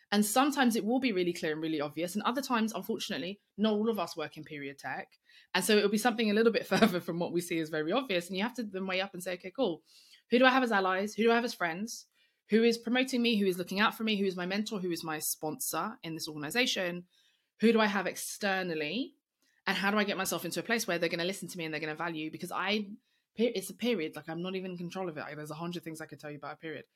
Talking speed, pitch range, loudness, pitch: 295 wpm, 170-225 Hz, -31 LUFS, 190 Hz